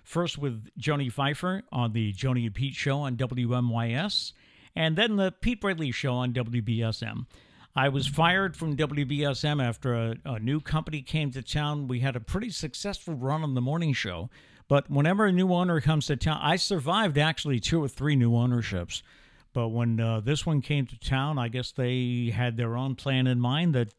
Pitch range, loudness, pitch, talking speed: 120-155 Hz, -28 LUFS, 135 Hz, 195 wpm